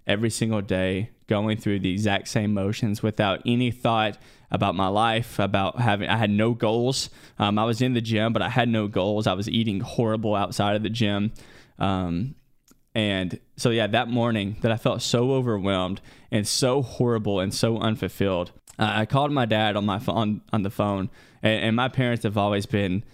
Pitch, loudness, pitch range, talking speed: 110 Hz, -24 LUFS, 100-115 Hz, 190 wpm